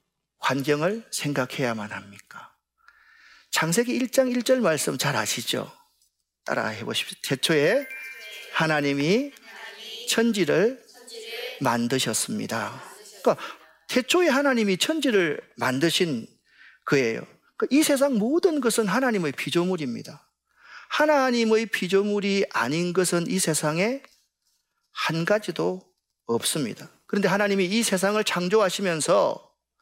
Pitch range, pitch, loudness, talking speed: 175-265 Hz, 215 Hz, -24 LUFS, 245 characters per minute